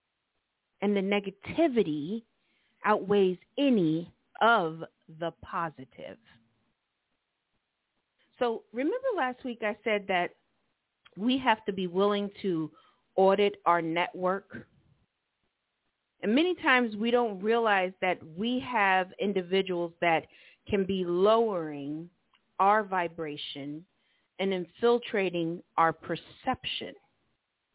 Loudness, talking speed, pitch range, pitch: -29 LUFS, 95 wpm, 170-225 Hz, 195 Hz